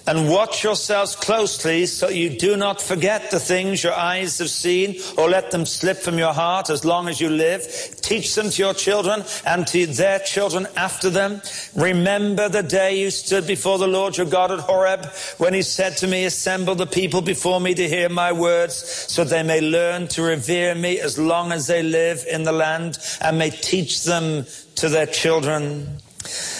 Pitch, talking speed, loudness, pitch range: 180 Hz, 195 wpm, -20 LUFS, 165-190 Hz